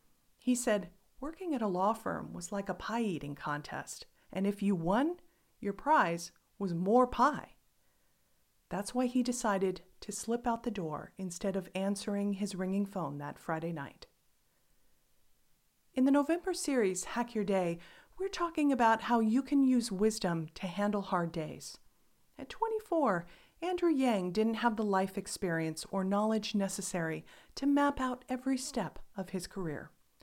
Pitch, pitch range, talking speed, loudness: 205 Hz, 185-250 Hz, 155 wpm, -33 LUFS